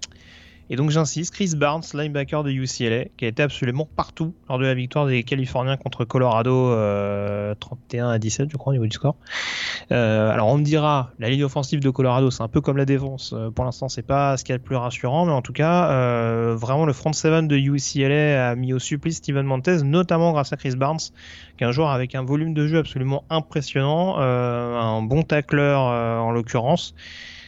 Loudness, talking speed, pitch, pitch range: -22 LUFS, 210 wpm, 135 Hz, 120-150 Hz